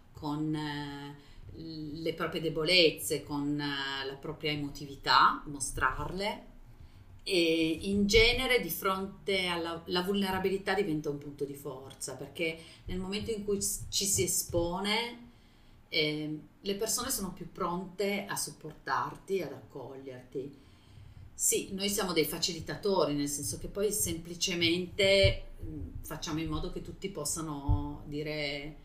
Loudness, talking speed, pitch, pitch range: -31 LUFS, 120 wpm, 160 Hz, 145-190 Hz